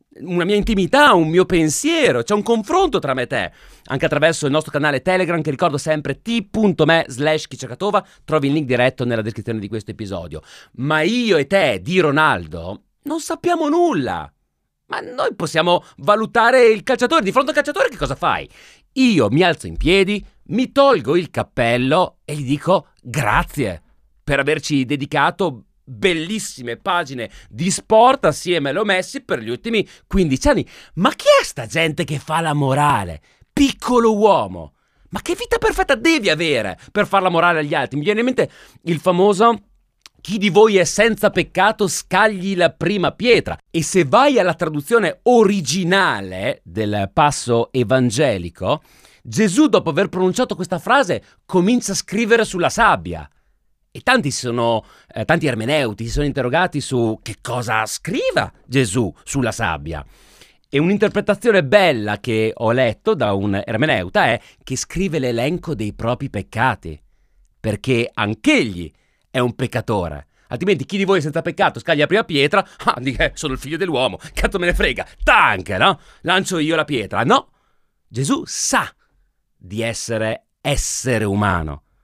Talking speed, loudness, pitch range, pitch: 155 wpm, -18 LUFS, 125-205 Hz, 155 Hz